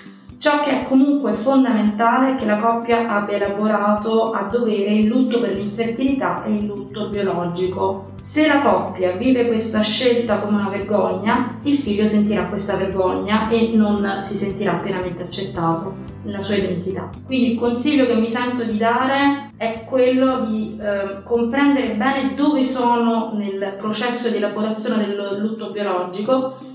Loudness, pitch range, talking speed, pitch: -19 LUFS, 200-245 Hz, 150 wpm, 220 Hz